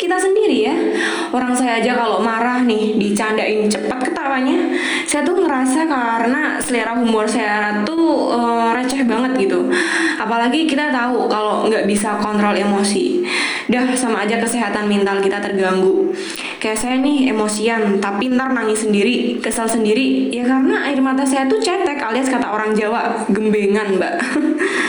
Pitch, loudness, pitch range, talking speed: 235 Hz, -17 LUFS, 215-275 Hz, 145 wpm